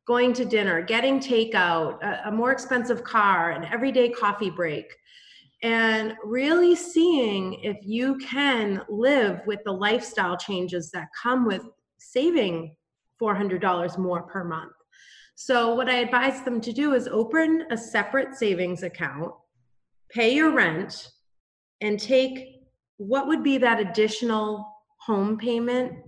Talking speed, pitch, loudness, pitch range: 130 wpm, 225 Hz, -24 LUFS, 185-255 Hz